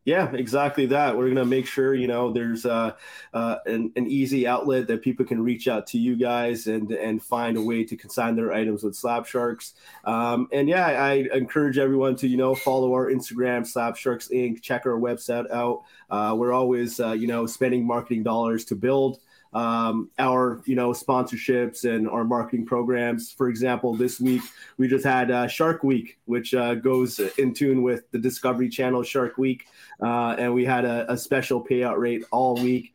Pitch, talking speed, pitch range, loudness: 125 Hz, 195 wpm, 120-130 Hz, -24 LUFS